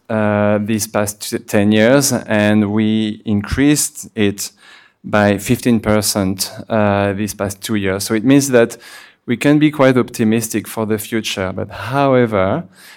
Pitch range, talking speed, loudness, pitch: 105-120 Hz, 140 wpm, -16 LUFS, 110 Hz